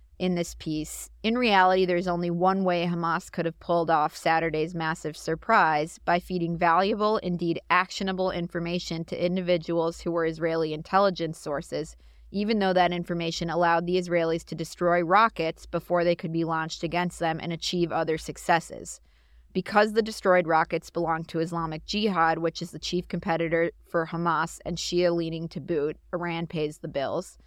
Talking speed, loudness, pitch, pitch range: 165 wpm, -26 LUFS, 170 Hz, 165-180 Hz